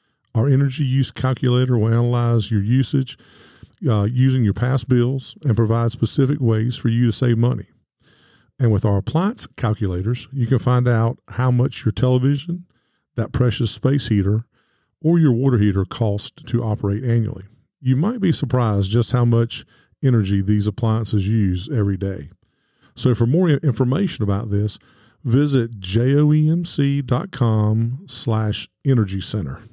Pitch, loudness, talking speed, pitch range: 120 Hz, -19 LUFS, 145 wpm, 110-130 Hz